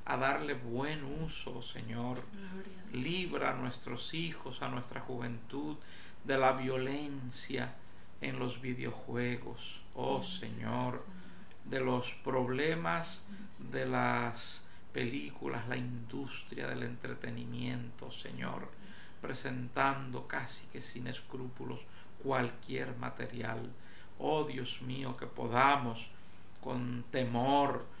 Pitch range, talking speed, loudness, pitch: 120-135 Hz, 95 wpm, -37 LUFS, 125 Hz